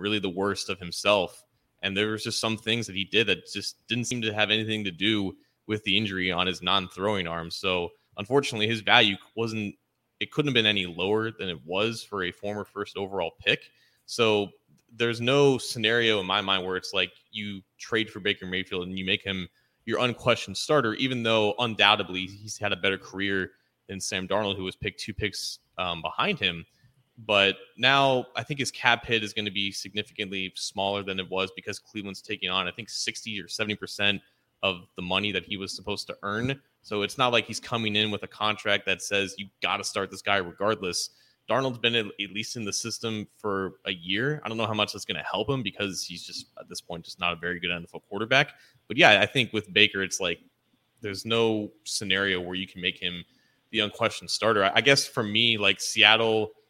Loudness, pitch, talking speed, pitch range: -26 LUFS, 105 Hz, 215 wpm, 95-115 Hz